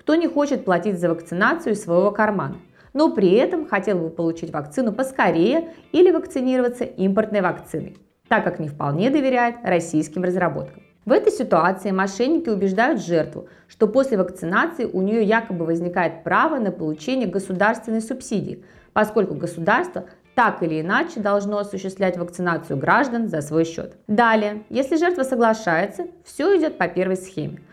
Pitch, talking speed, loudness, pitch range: 205 Hz, 145 wpm, -21 LUFS, 175-255 Hz